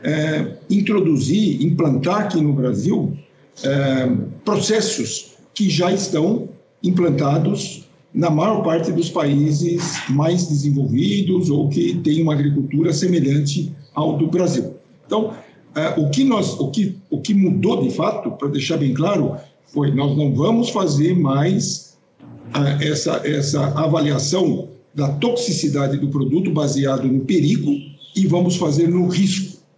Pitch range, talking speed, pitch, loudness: 145-180 Hz, 135 wpm, 160 Hz, -19 LUFS